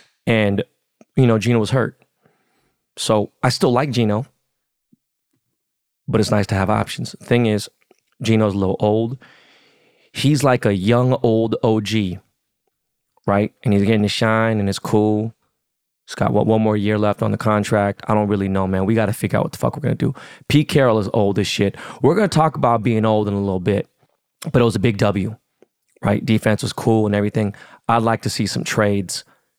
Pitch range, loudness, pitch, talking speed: 105-115 Hz, -19 LUFS, 110 Hz, 205 wpm